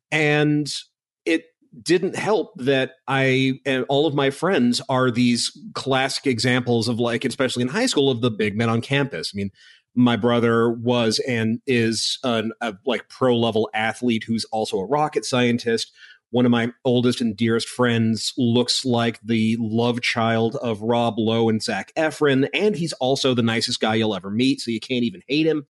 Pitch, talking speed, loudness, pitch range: 120 Hz, 180 wpm, -21 LUFS, 115-135 Hz